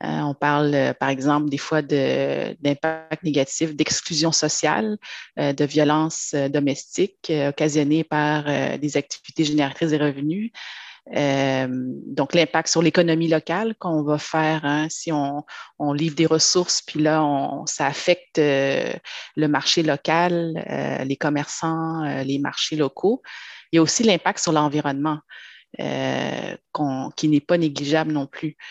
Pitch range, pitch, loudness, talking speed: 145-160 Hz, 150 Hz, -22 LUFS, 135 wpm